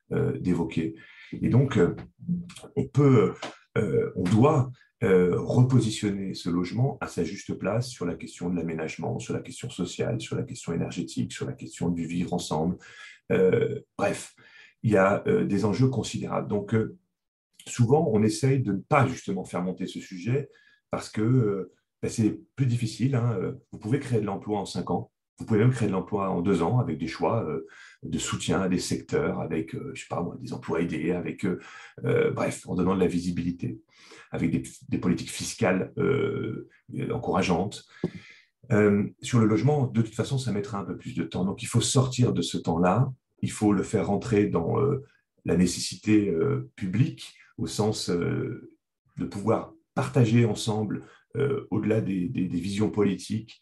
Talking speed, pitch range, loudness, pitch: 170 wpm, 90-125 Hz, -27 LUFS, 105 Hz